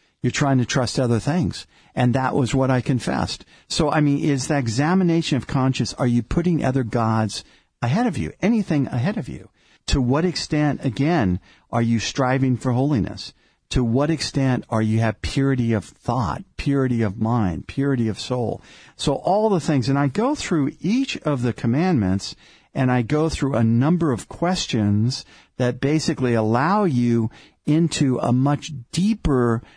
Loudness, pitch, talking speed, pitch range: -21 LUFS, 130 Hz, 170 wpm, 120-150 Hz